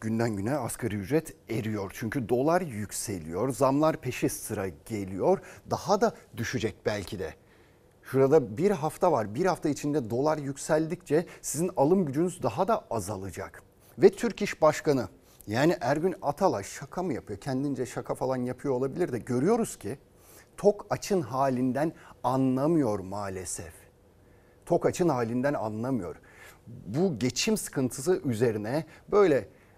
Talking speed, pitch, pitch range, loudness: 130 wpm, 135 Hz, 115-160 Hz, -28 LUFS